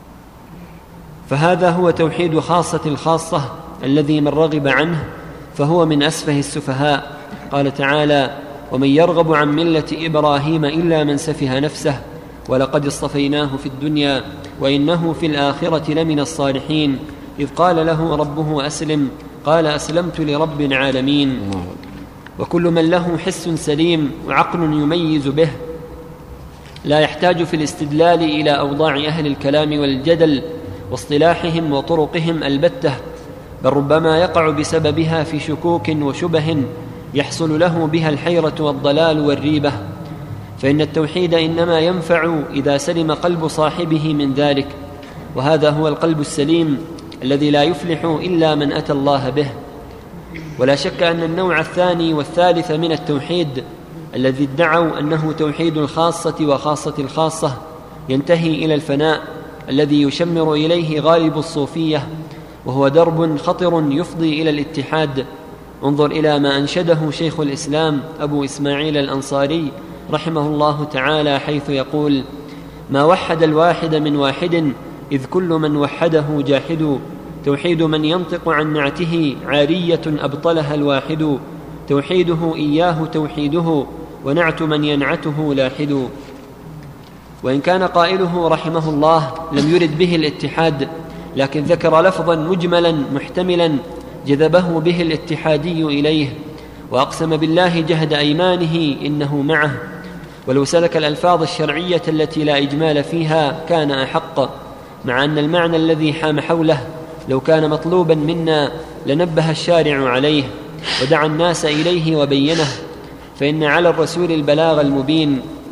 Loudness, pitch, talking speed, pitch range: -16 LUFS, 155 Hz, 115 wpm, 145-165 Hz